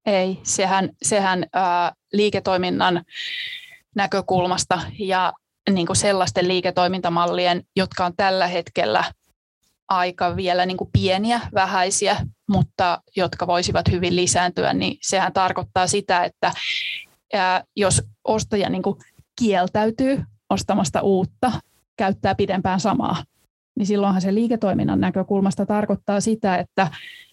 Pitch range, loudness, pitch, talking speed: 180-200 Hz, -21 LUFS, 190 Hz, 105 wpm